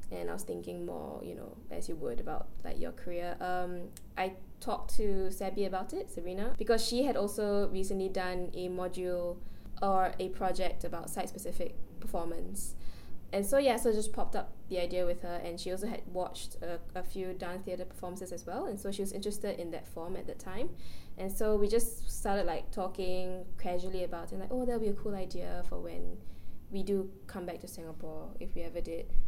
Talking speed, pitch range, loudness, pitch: 210 wpm, 175-200 Hz, -37 LUFS, 185 Hz